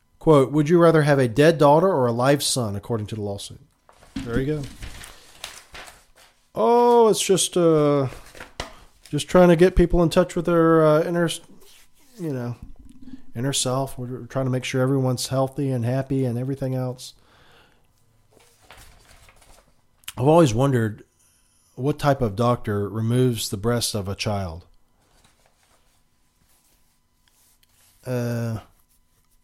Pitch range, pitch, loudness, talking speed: 105-150 Hz, 125 Hz, -21 LUFS, 130 wpm